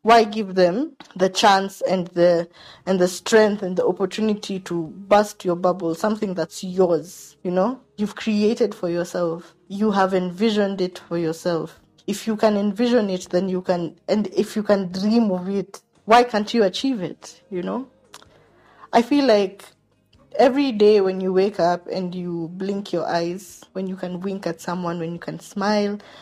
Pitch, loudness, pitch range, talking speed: 190 Hz, -21 LUFS, 175-210 Hz, 180 wpm